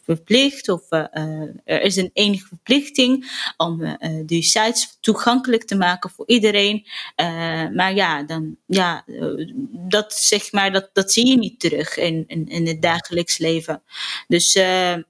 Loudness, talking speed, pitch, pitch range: -19 LUFS, 150 wpm, 185 Hz, 165-215 Hz